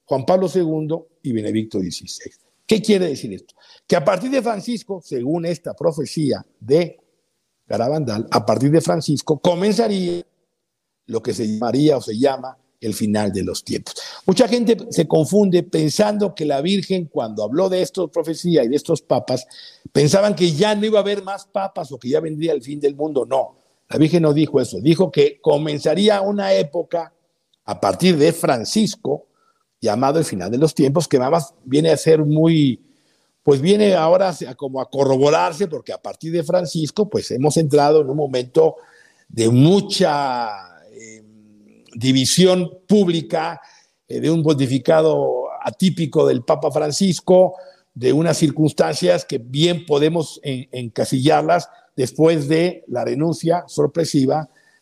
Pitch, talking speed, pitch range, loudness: 160 Hz, 155 wpm, 140-185 Hz, -18 LUFS